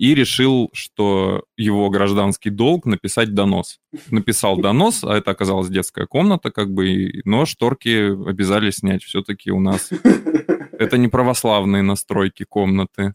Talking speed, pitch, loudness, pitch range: 130 wpm, 100 Hz, -18 LUFS, 100-115 Hz